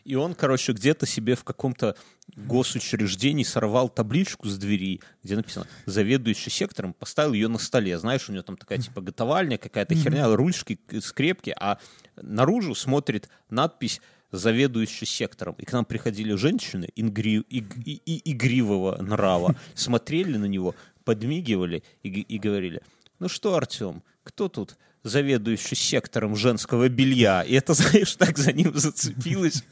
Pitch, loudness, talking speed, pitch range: 125 Hz, -25 LUFS, 140 wpm, 110-145 Hz